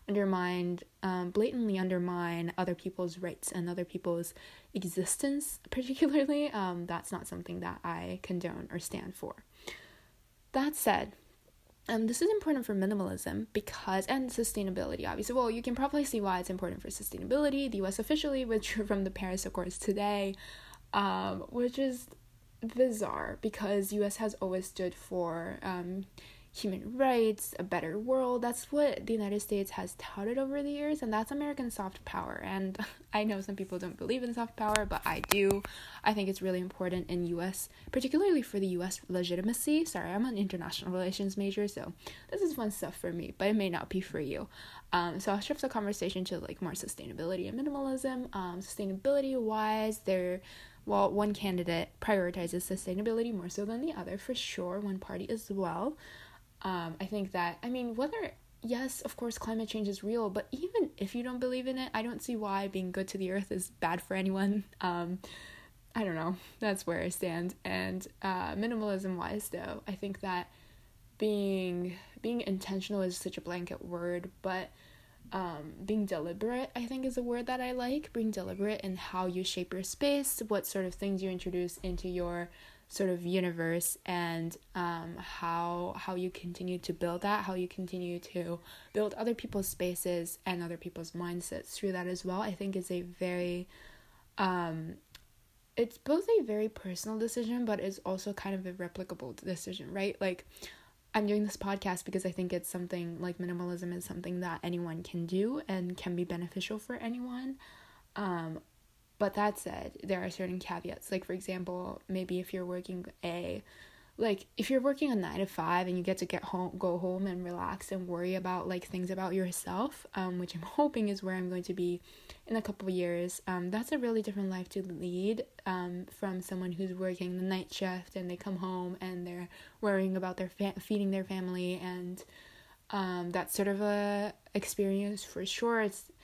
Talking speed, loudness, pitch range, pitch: 185 wpm, -35 LUFS, 180-215 Hz, 190 Hz